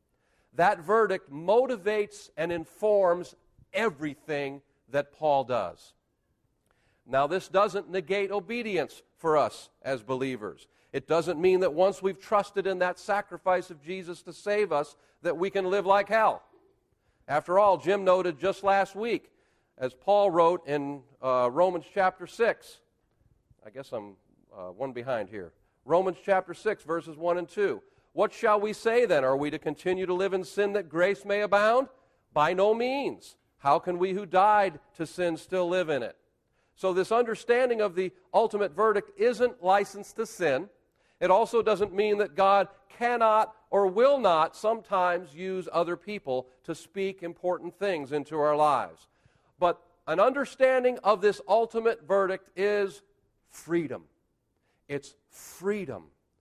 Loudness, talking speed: -27 LUFS, 150 wpm